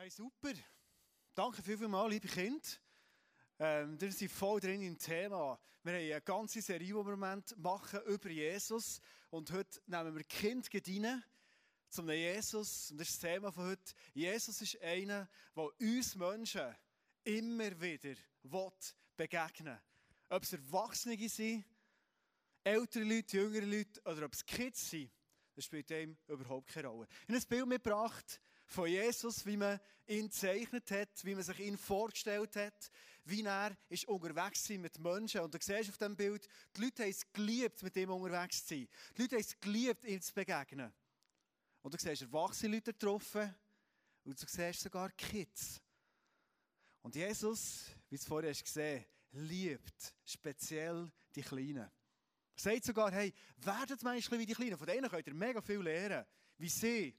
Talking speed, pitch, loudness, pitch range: 165 wpm, 195 Hz, -42 LUFS, 170-220 Hz